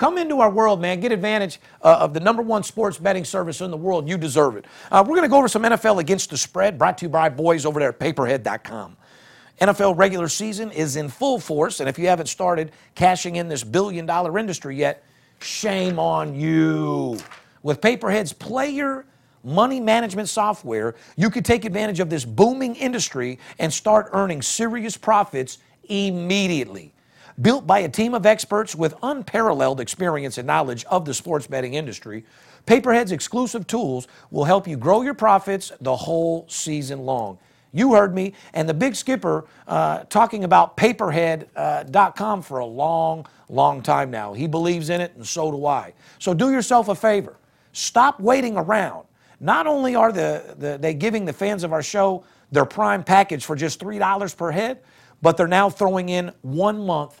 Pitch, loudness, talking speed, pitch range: 185 Hz, -21 LUFS, 185 wpm, 155-215 Hz